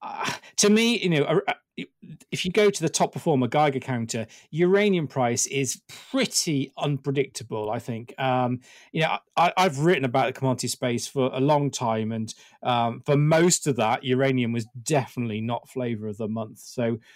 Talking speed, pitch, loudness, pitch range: 180 wpm, 135 Hz, -24 LUFS, 120-165 Hz